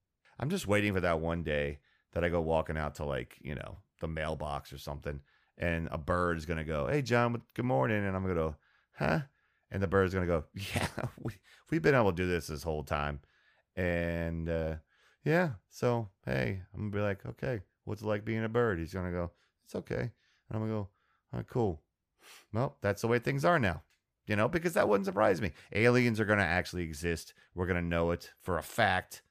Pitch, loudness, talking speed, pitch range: 90 Hz, -33 LUFS, 210 wpm, 80-105 Hz